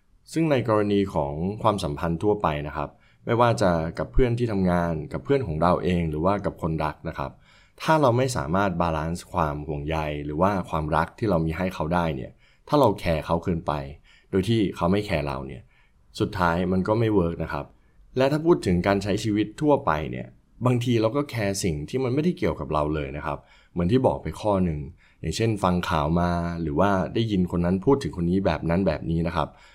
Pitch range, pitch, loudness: 80-105 Hz, 90 Hz, -25 LUFS